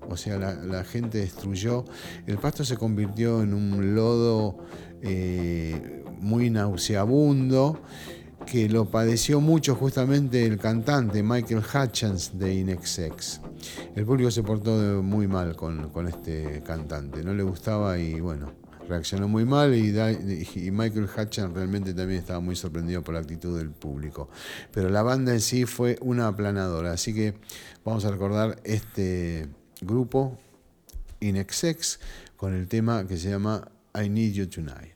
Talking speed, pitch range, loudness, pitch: 145 wpm, 85-115 Hz, -27 LUFS, 100 Hz